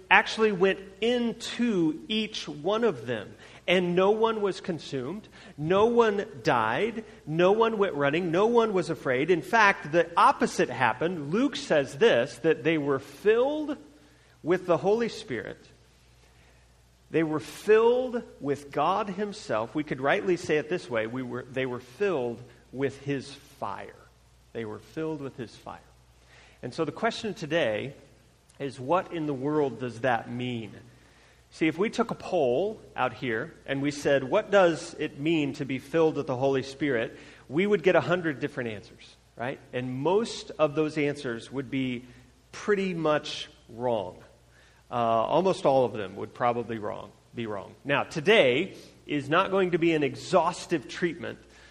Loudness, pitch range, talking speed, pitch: -27 LUFS, 130-195 Hz, 160 wpm, 155 Hz